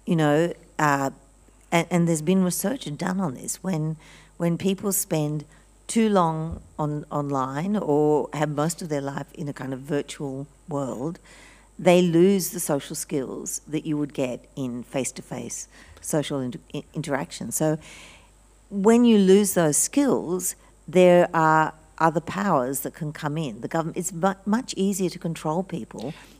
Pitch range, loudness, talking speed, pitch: 145-180 Hz, -24 LUFS, 150 wpm, 160 Hz